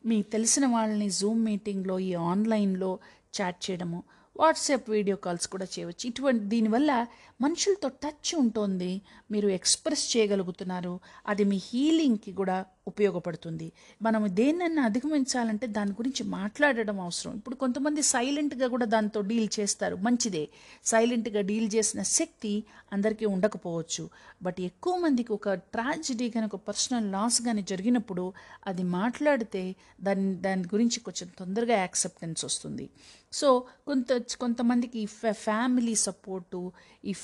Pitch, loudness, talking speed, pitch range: 215 Hz, -28 LUFS, 120 wpm, 195-245 Hz